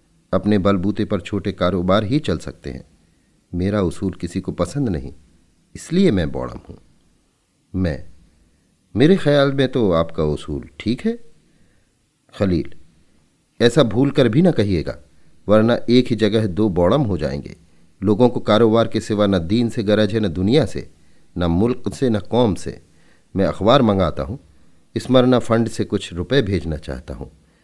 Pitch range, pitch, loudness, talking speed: 85-115 Hz, 100 Hz, -19 LUFS, 160 wpm